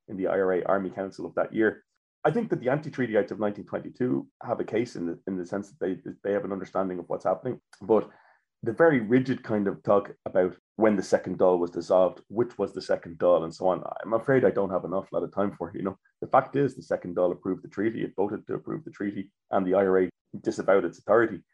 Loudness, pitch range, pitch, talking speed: -27 LUFS, 90-120 Hz, 100 Hz, 250 wpm